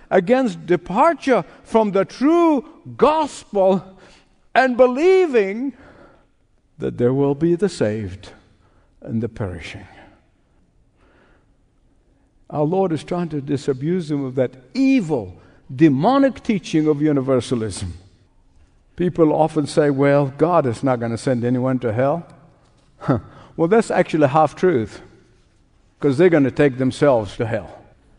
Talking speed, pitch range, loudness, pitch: 125 wpm, 125-190 Hz, -19 LUFS, 150 Hz